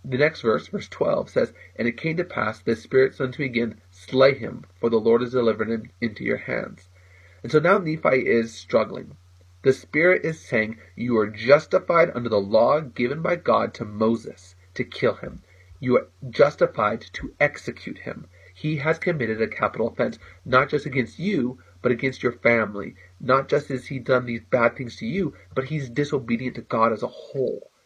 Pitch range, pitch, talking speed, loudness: 110-135 Hz, 120 Hz, 190 wpm, -23 LUFS